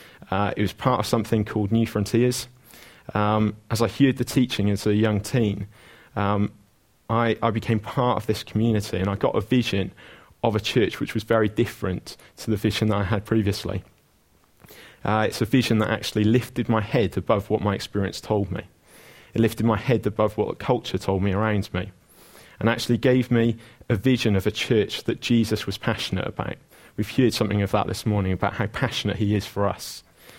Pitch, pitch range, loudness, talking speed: 110 Hz, 105-115 Hz, -24 LUFS, 200 wpm